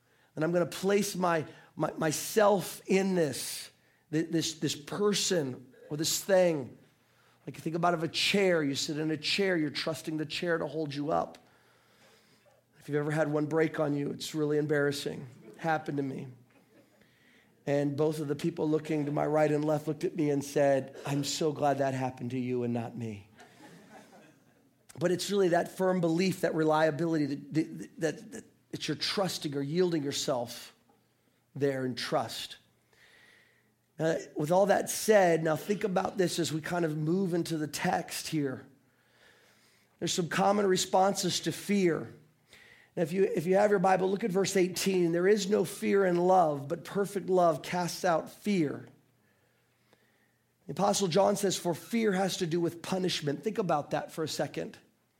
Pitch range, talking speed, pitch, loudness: 145-185 Hz, 175 wpm, 160 Hz, -30 LUFS